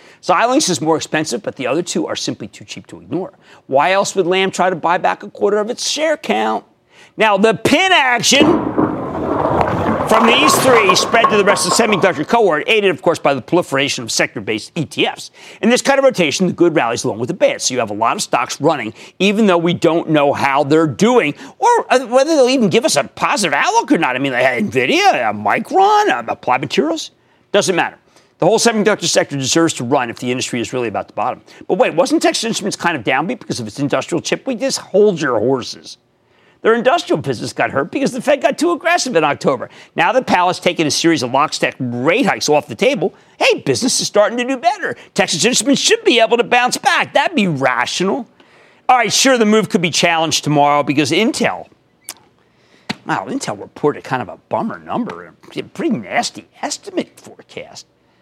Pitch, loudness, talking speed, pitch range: 195 Hz, -15 LUFS, 210 wpm, 155-255 Hz